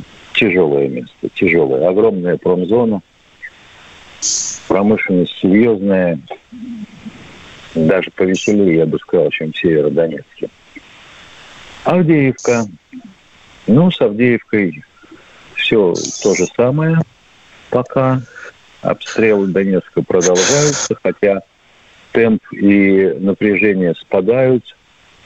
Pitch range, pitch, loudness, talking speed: 95-140 Hz, 110 Hz, -14 LUFS, 75 wpm